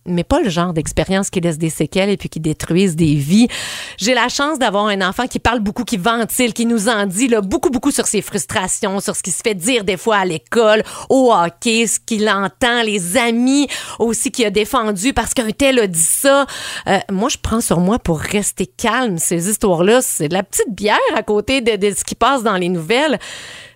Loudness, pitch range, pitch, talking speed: -16 LUFS, 190-240 Hz, 215 Hz, 225 wpm